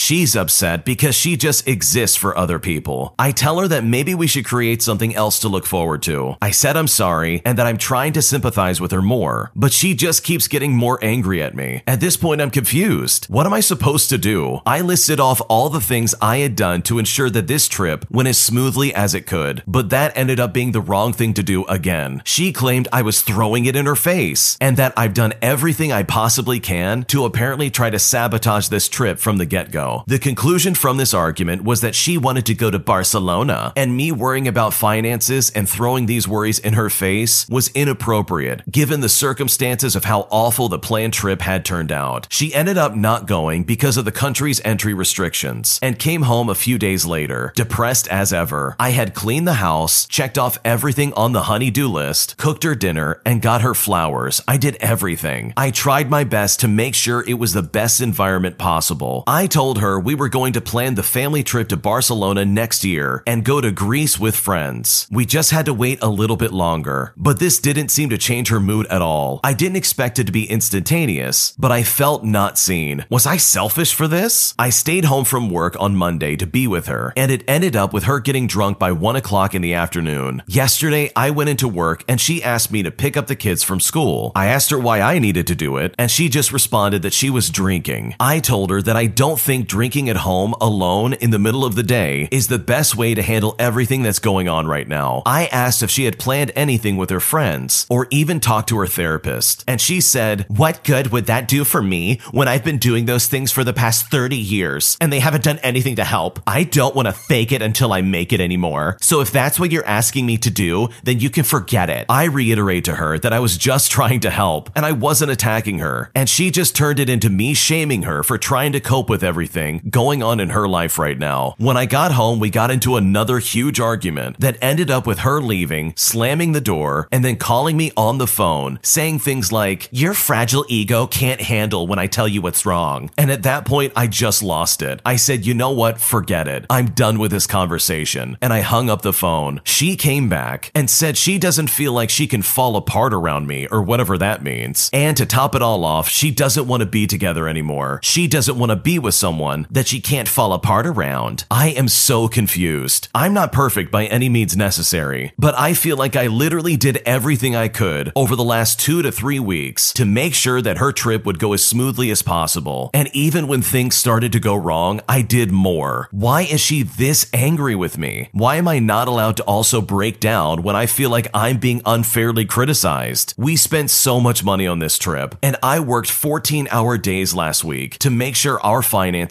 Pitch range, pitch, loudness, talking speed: 100-135 Hz, 120 Hz, -16 LUFS, 225 wpm